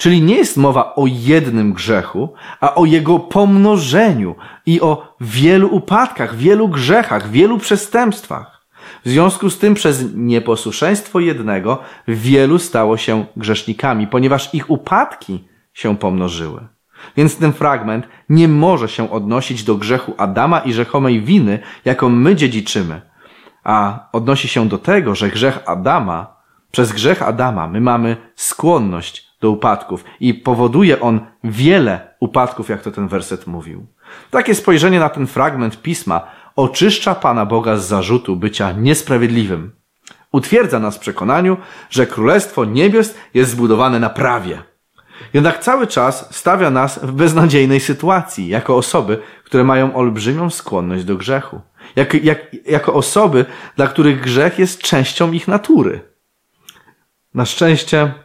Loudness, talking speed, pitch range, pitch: -14 LUFS, 135 wpm, 115-170 Hz, 130 Hz